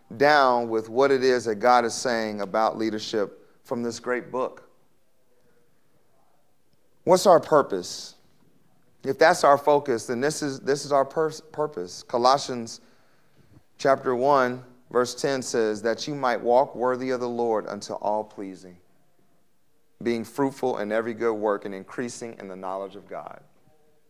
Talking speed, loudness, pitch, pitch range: 150 wpm, -24 LUFS, 125 Hz, 110-140 Hz